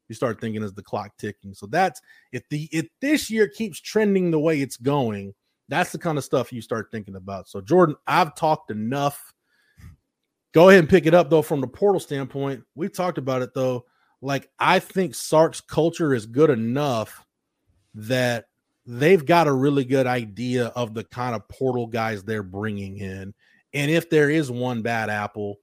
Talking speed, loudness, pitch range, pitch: 190 wpm, -22 LUFS, 115-160 Hz, 135 Hz